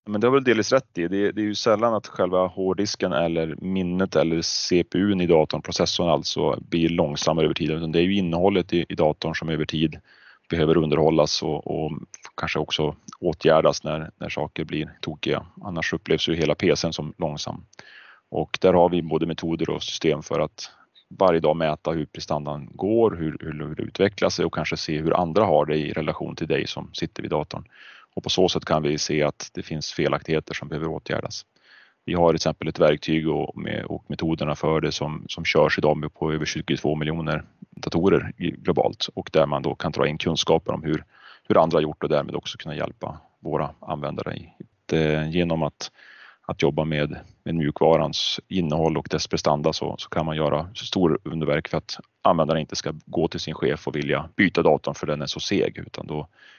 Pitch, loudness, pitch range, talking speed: 80 Hz, -24 LUFS, 75-90 Hz, 200 wpm